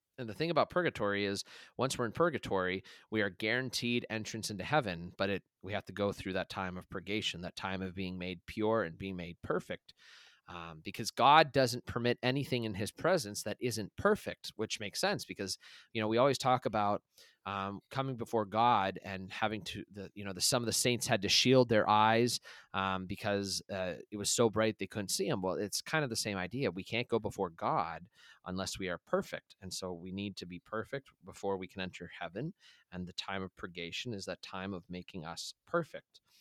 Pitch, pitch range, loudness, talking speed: 100 Hz, 95-115 Hz, -34 LUFS, 215 wpm